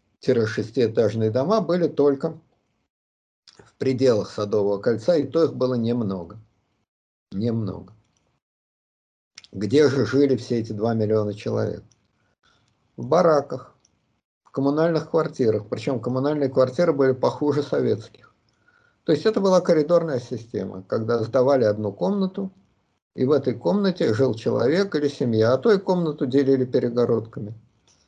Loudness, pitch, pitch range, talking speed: -22 LUFS, 125 Hz, 110-150 Hz, 120 wpm